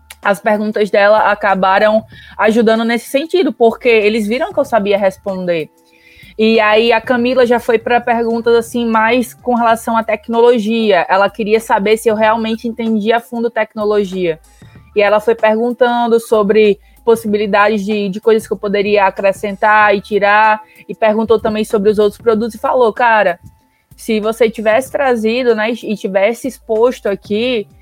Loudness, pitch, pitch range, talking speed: -13 LUFS, 220 Hz, 210-235 Hz, 155 wpm